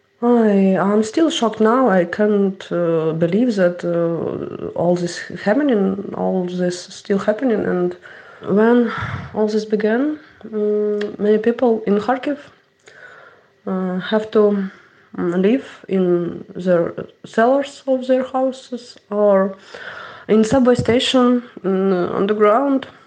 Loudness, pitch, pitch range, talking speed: -18 LUFS, 210 Hz, 190-245 Hz, 110 wpm